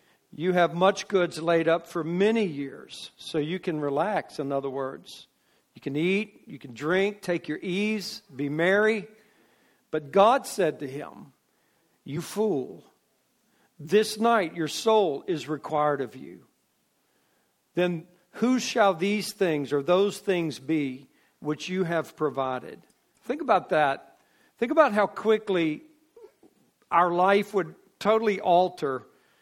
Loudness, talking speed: -26 LUFS, 135 wpm